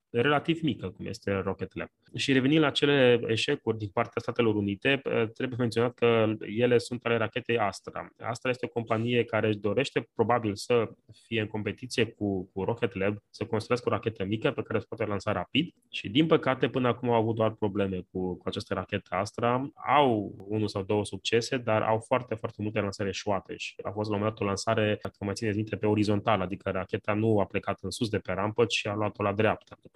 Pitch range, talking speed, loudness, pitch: 100-120 Hz, 210 wpm, -29 LUFS, 110 Hz